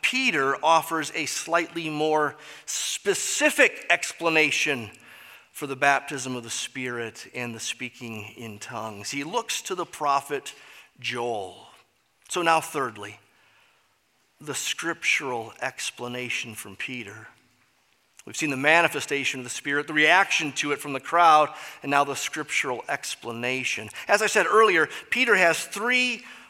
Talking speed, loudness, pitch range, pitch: 130 wpm, -24 LUFS, 125-165 Hz, 145 Hz